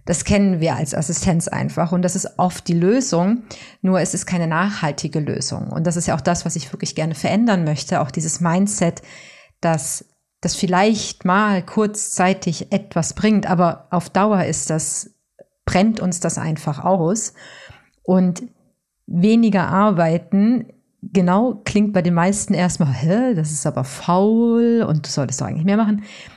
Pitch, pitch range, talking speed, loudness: 180 Hz, 165-205 Hz, 160 wpm, -19 LUFS